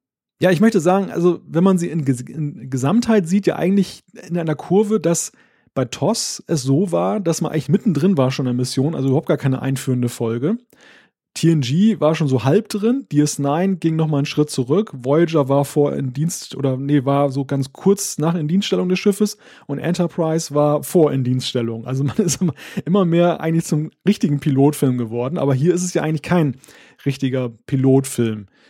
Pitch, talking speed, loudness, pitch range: 155 Hz, 195 wpm, -19 LUFS, 135-185 Hz